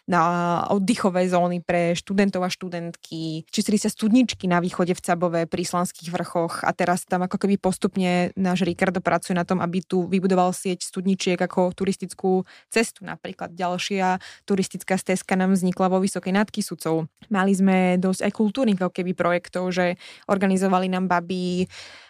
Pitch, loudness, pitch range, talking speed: 185 Hz, -23 LUFS, 175-195 Hz, 155 wpm